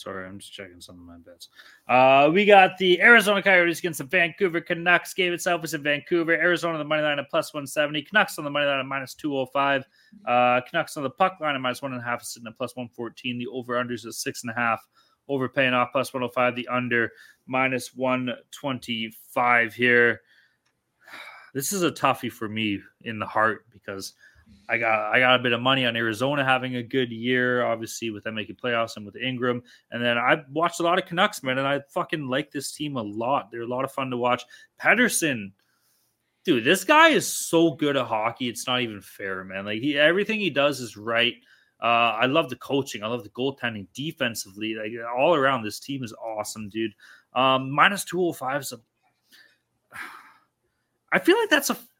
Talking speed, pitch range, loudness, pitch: 205 wpm, 115-150 Hz, -23 LUFS, 130 Hz